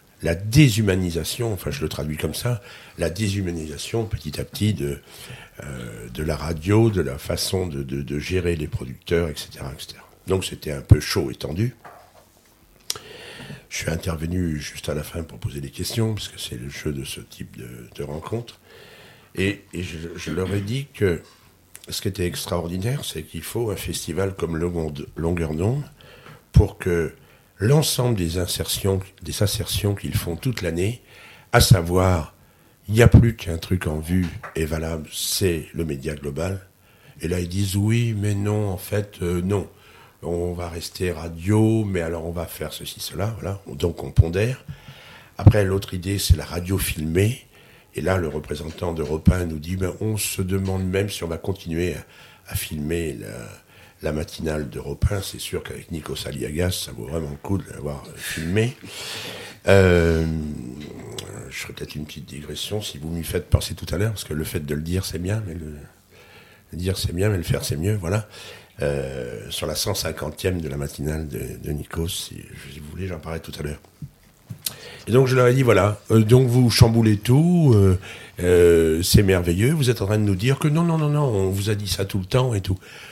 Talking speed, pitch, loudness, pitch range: 195 wpm, 95 Hz, -23 LUFS, 80-105 Hz